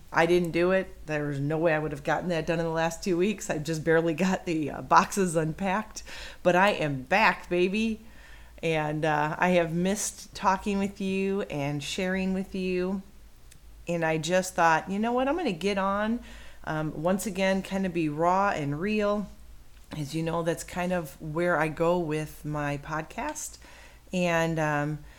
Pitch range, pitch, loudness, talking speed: 155-190 Hz, 175 Hz, -27 LUFS, 185 wpm